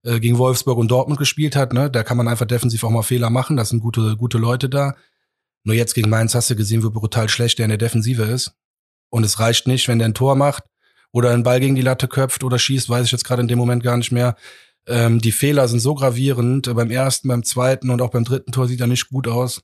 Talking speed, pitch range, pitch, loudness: 260 wpm, 115-130 Hz, 120 Hz, -18 LUFS